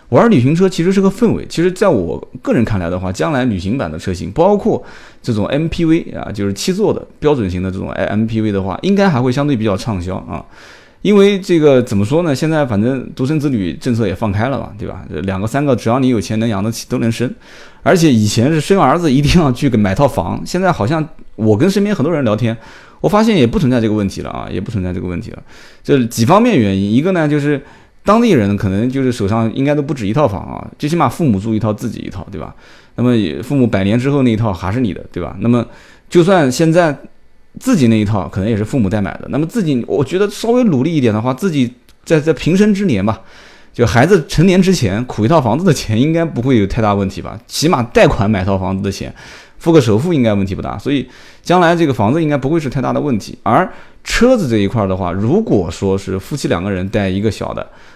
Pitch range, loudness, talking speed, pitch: 100-155 Hz, -14 LUFS, 355 characters per minute, 120 Hz